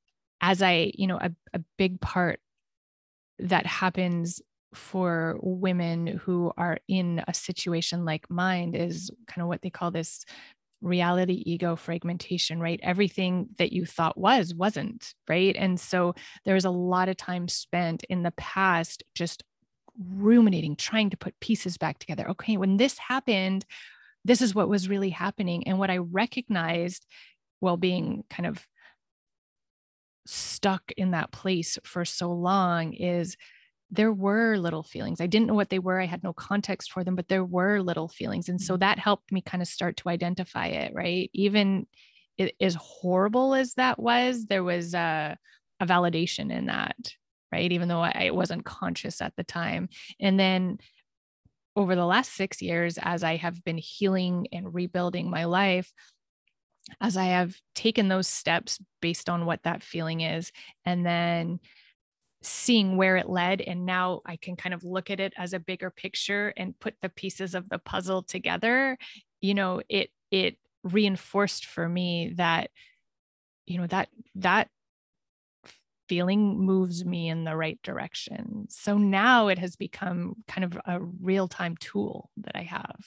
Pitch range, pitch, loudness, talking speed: 175-200 Hz, 185 Hz, -27 LUFS, 165 wpm